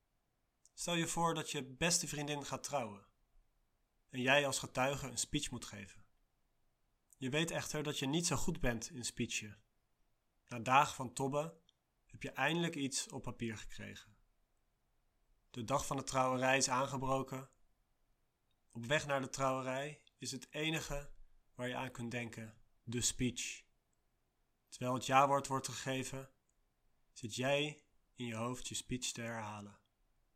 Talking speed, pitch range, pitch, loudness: 150 wpm, 115-140 Hz, 130 Hz, -38 LUFS